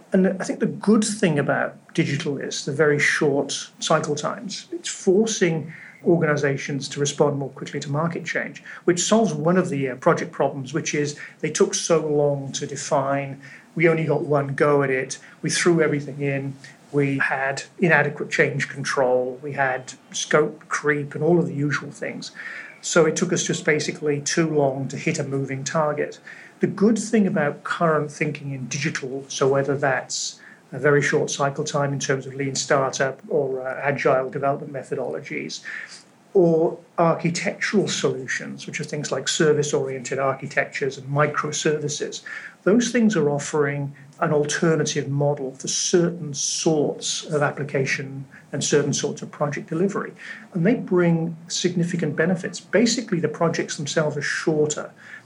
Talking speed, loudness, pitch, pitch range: 155 wpm, -22 LUFS, 150 Hz, 140-175 Hz